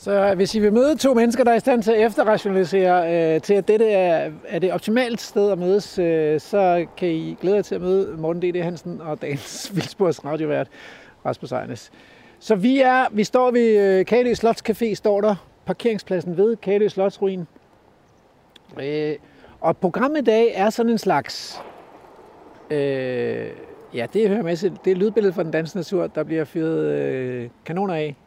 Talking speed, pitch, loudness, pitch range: 180 wpm, 195 Hz, -20 LUFS, 165-220 Hz